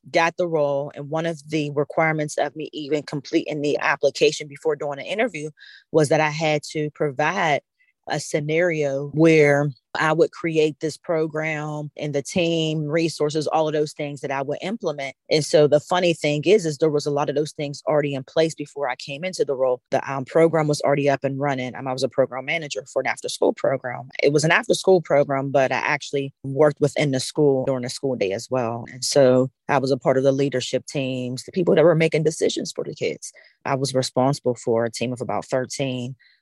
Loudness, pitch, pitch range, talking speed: -22 LUFS, 150 Hz, 135-155 Hz, 220 wpm